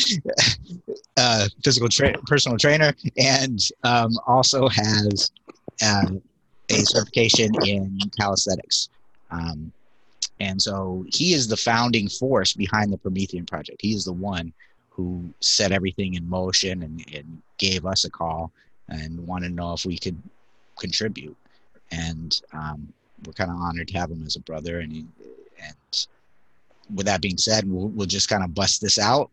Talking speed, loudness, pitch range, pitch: 155 wpm, -22 LUFS, 85-110 Hz, 95 Hz